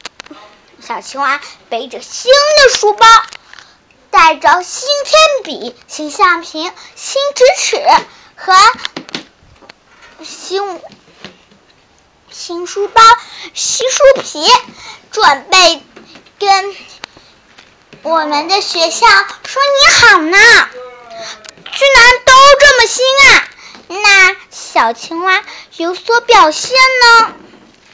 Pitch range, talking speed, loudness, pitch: 290-445 Hz, 120 characters per minute, -8 LUFS, 355 Hz